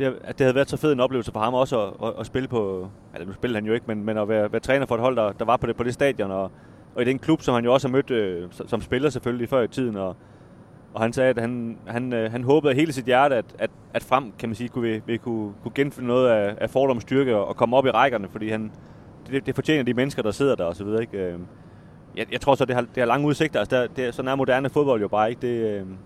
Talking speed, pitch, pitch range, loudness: 300 wpm, 120 Hz, 110-135 Hz, -23 LUFS